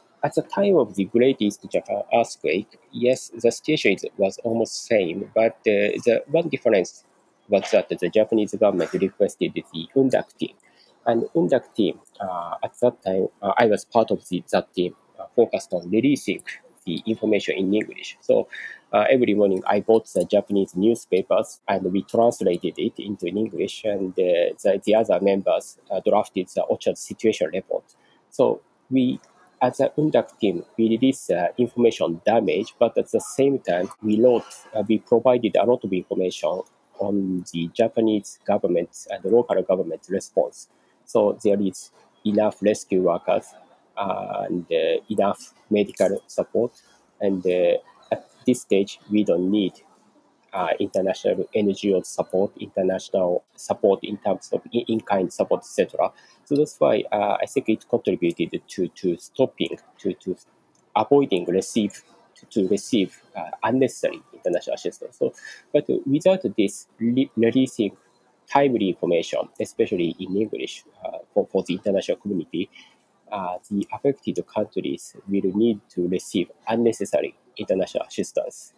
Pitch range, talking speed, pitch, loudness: 100-135 Hz, 150 wpm, 110 Hz, -23 LUFS